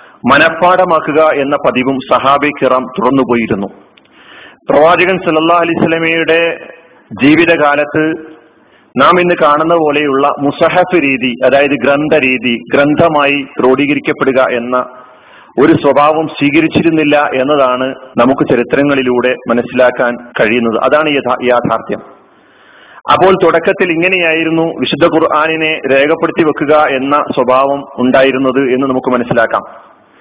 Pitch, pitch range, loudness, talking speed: 145 Hz, 130-160 Hz, -10 LUFS, 95 wpm